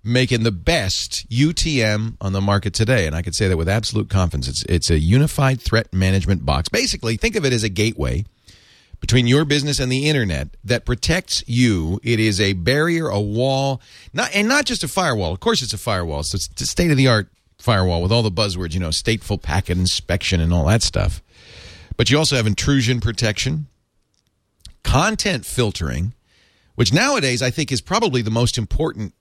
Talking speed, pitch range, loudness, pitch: 195 wpm, 90-130 Hz, -19 LUFS, 110 Hz